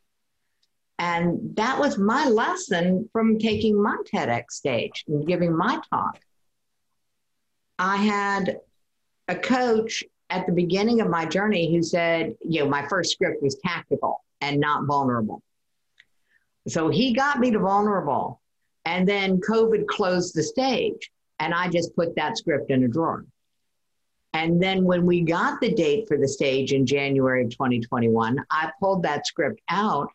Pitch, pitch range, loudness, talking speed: 175 Hz, 150-210 Hz, -23 LUFS, 150 wpm